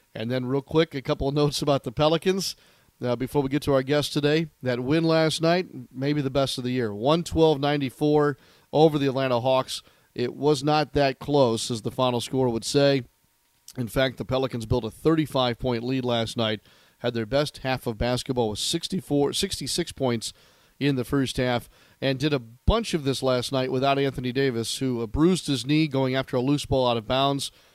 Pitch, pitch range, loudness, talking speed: 135 Hz, 125-150 Hz, -25 LUFS, 200 wpm